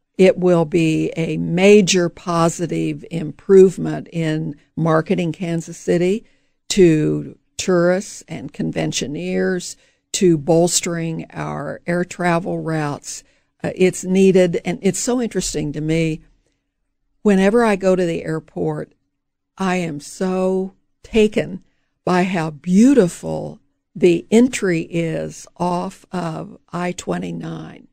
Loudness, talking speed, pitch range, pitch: -18 LUFS, 105 wpm, 160-185 Hz, 175 Hz